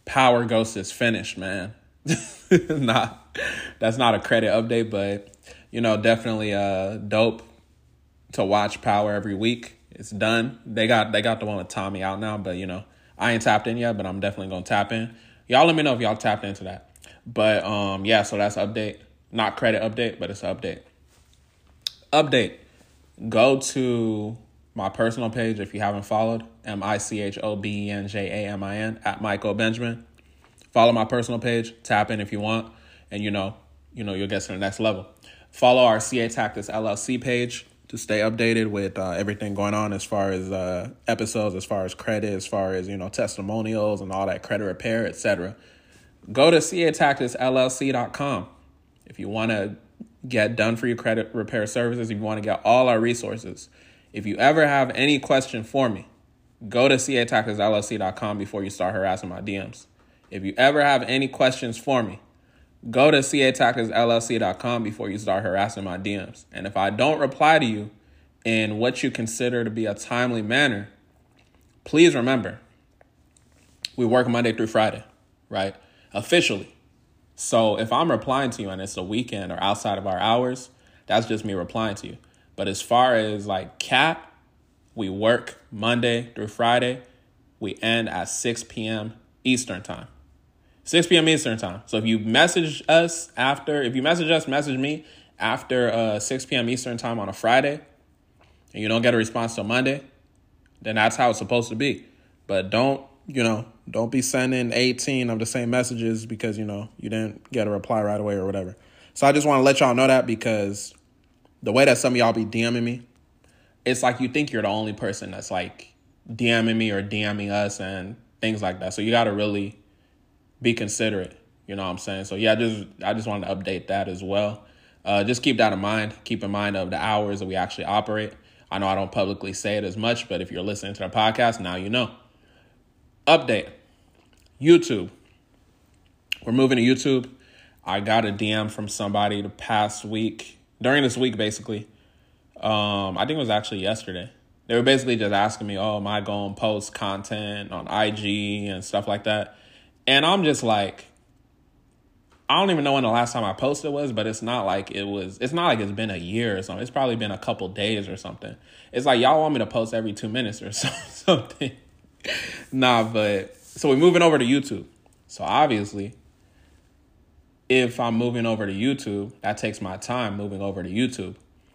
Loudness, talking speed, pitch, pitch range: -23 LUFS, 190 wpm, 110 Hz, 100-120 Hz